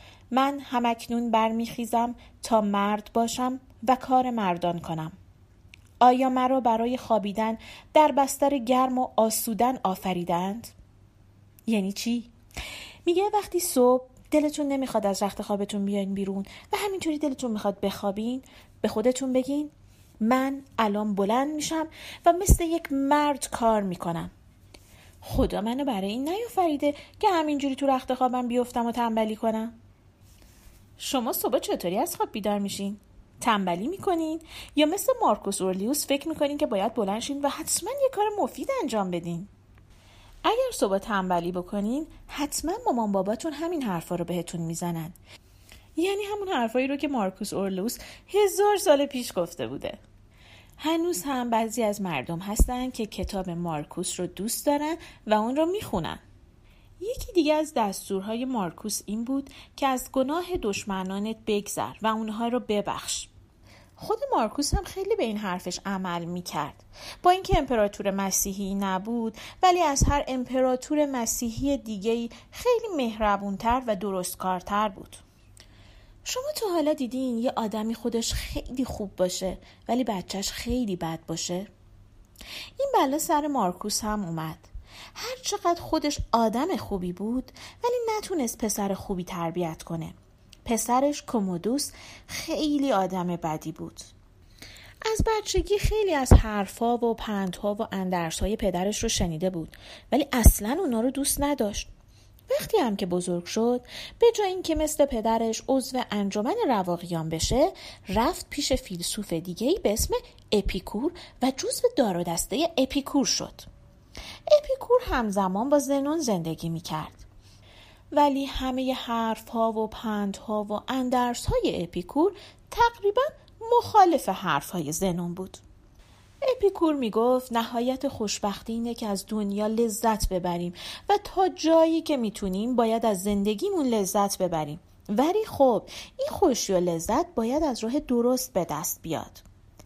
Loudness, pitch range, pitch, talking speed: -27 LUFS, 190-290 Hz, 230 Hz, 135 wpm